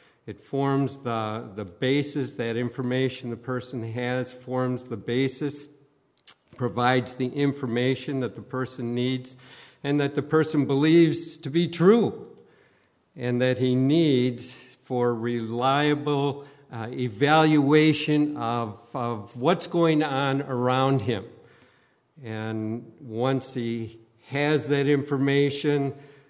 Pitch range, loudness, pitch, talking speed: 120-145 Hz, -25 LUFS, 130 Hz, 110 wpm